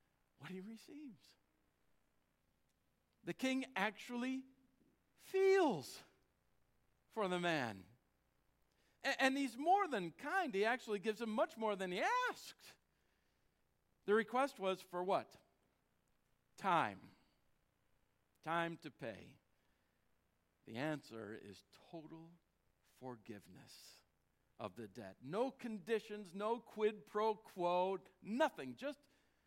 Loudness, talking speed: -40 LUFS, 100 wpm